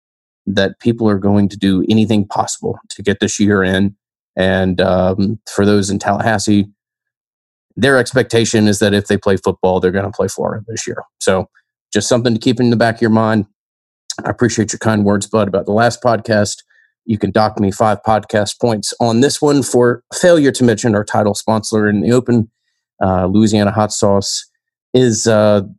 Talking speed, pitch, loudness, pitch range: 190 wpm, 105 Hz, -14 LUFS, 100-115 Hz